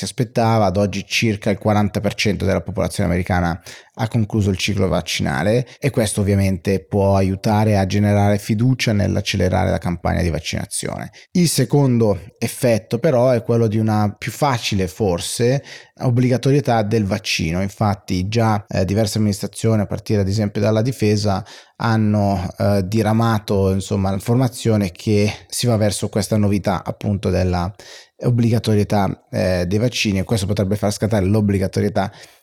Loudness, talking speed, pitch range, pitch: -19 LUFS, 140 wpm, 95-115 Hz, 105 Hz